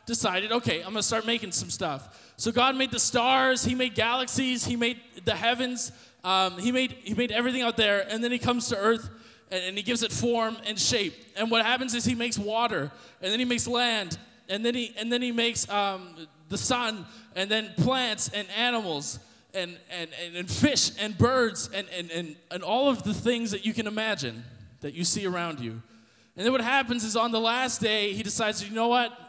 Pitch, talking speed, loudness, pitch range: 225 Hz, 220 wpm, -26 LUFS, 190-240 Hz